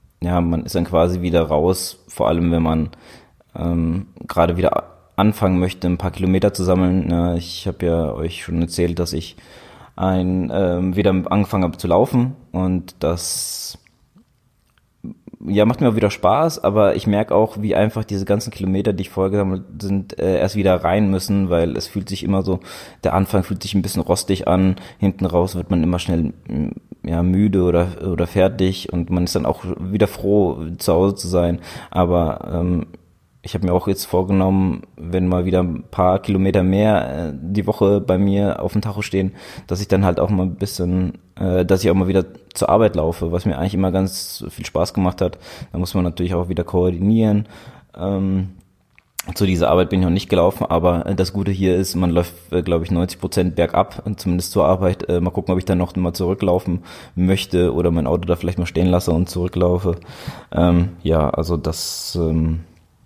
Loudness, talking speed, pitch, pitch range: -19 LUFS, 190 wpm, 90 Hz, 85-95 Hz